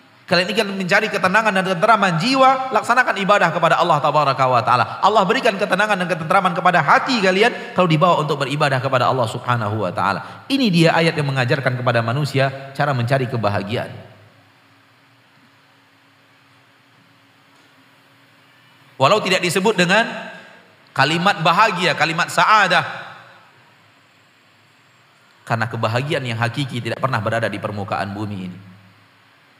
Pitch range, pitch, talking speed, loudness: 125-190 Hz, 140 Hz, 120 wpm, -17 LUFS